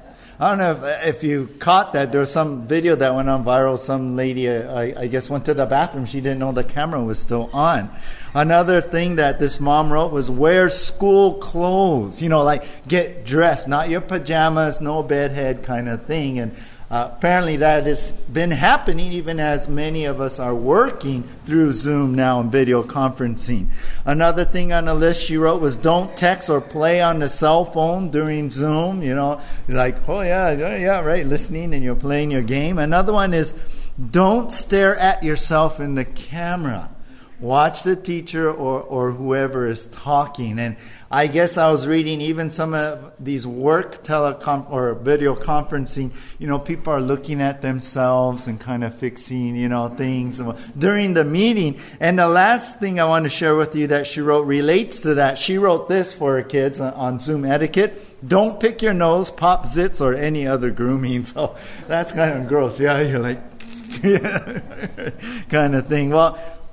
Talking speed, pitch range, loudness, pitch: 185 wpm, 130-165 Hz, -19 LUFS, 150 Hz